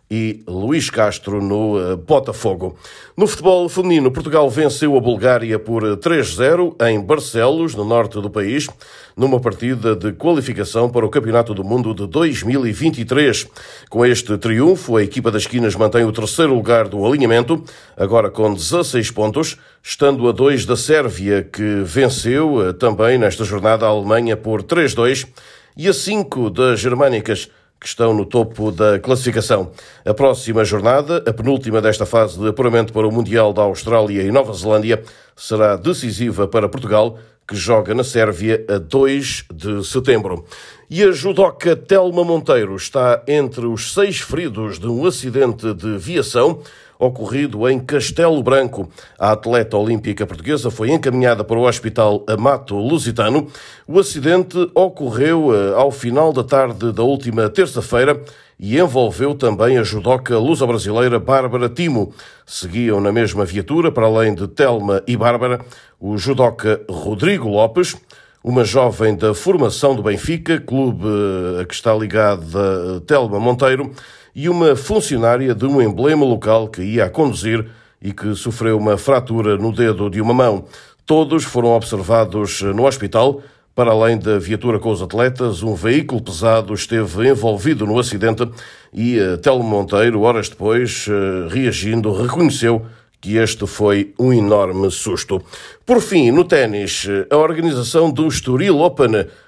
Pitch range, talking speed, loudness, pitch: 105-135 Hz, 145 wpm, -16 LUFS, 115 Hz